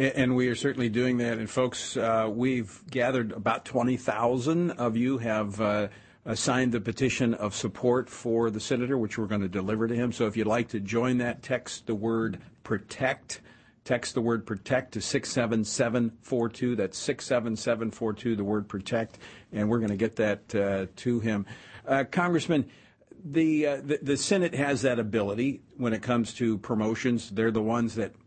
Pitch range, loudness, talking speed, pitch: 110-125 Hz, -28 LUFS, 175 wpm, 115 Hz